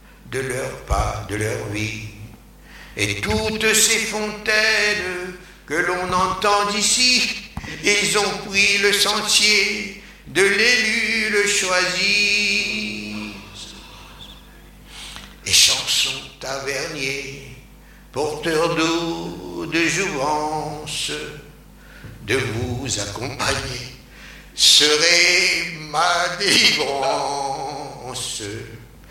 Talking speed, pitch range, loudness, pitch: 75 wpm, 125-205 Hz, -18 LUFS, 160 Hz